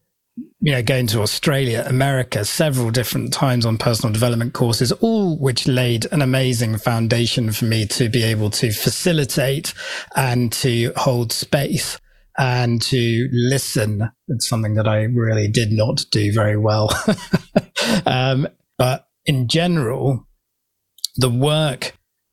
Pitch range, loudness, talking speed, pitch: 115-135 Hz, -19 LUFS, 130 wpm, 125 Hz